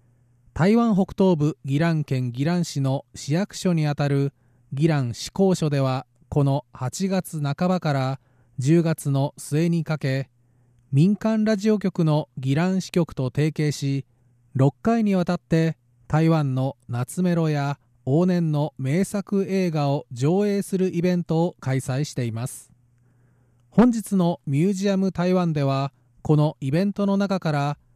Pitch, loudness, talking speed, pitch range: 150 Hz, -23 LUFS, 250 characters per minute, 130-180 Hz